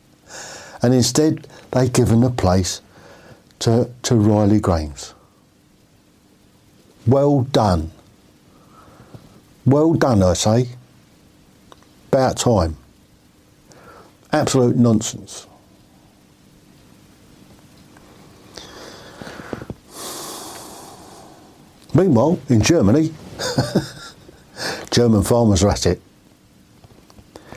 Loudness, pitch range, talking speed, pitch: -18 LUFS, 100-130 Hz, 65 wpm, 115 Hz